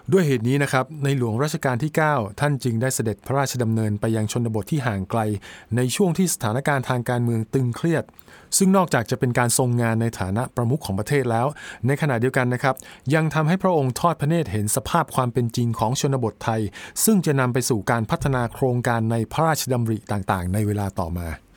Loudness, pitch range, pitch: -22 LUFS, 110-145 Hz, 125 Hz